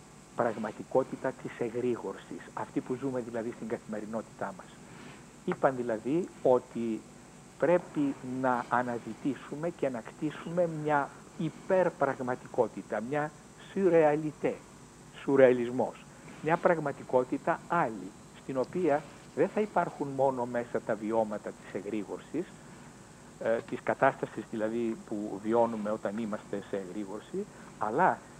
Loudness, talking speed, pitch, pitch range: -32 LUFS, 100 wpm, 130 Hz, 115-150 Hz